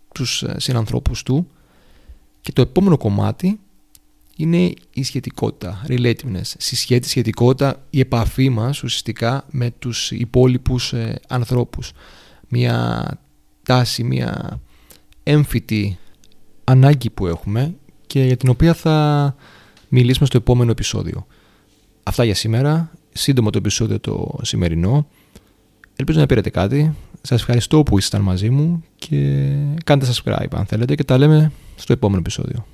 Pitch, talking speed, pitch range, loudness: 125 Hz, 120 wpm, 105-140 Hz, -18 LUFS